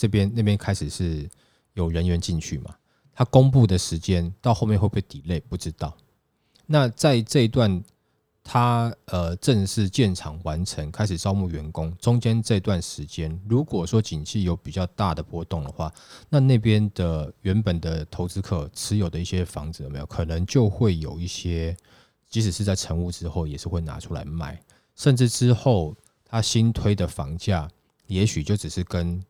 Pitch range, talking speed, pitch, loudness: 85-110 Hz, 265 characters per minute, 95 Hz, -24 LUFS